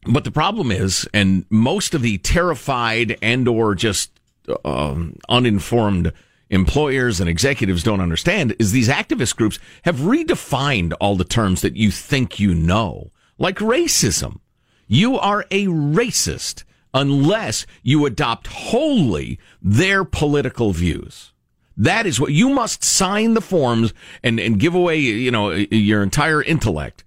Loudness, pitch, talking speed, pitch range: -18 LUFS, 115 Hz, 135 wpm, 100-150 Hz